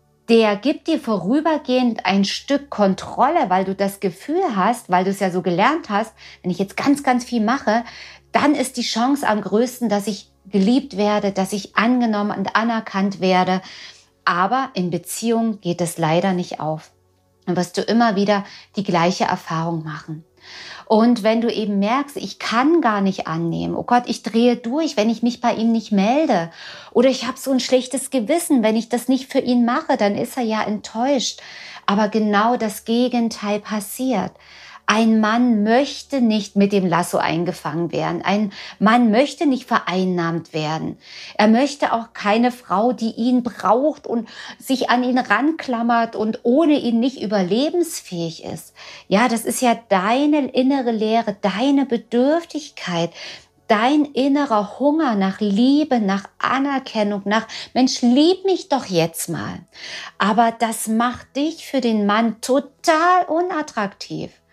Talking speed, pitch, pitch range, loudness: 160 wpm, 225 Hz, 200-255 Hz, -19 LUFS